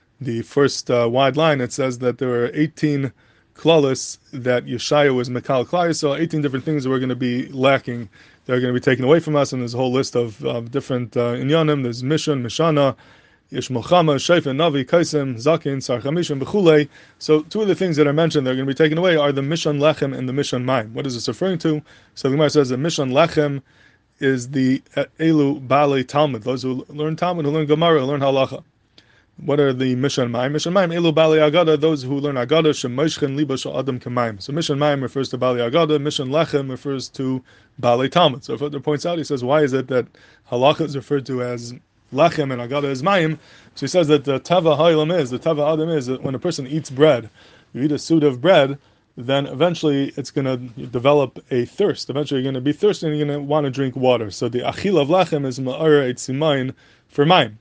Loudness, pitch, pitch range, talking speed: -19 LUFS, 140 Hz, 125-155 Hz, 220 wpm